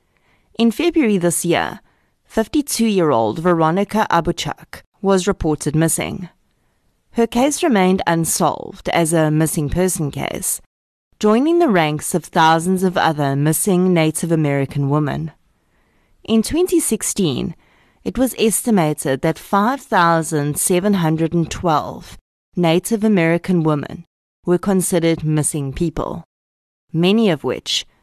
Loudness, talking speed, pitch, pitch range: -17 LUFS, 105 wpm, 170 Hz, 155-200 Hz